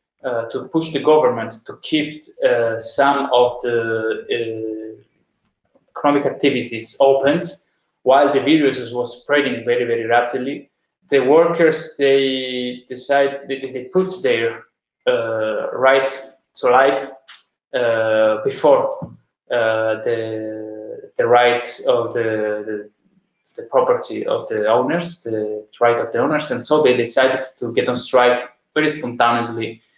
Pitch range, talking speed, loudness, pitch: 115-150 Hz, 125 wpm, -18 LUFS, 125 Hz